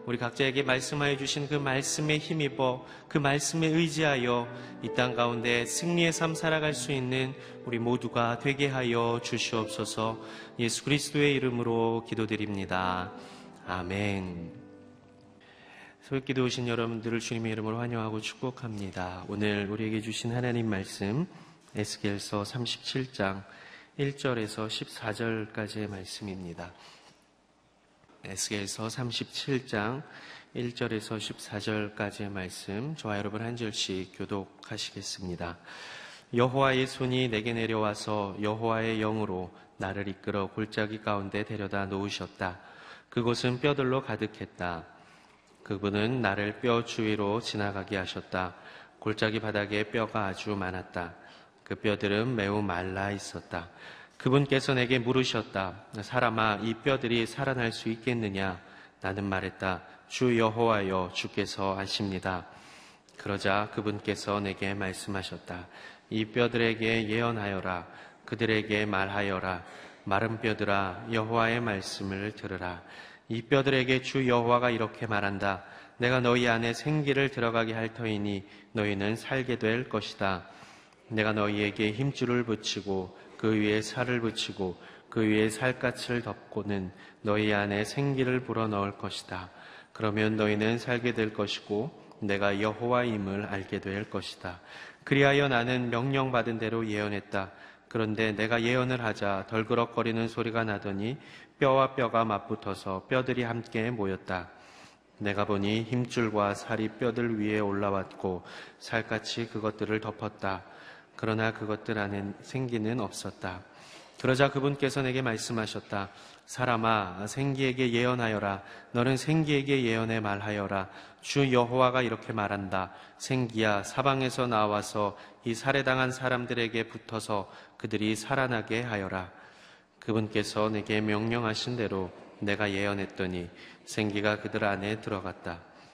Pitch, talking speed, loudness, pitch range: 110 Hz, 290 characters per minute, -30 LUFS, 100-120 Hz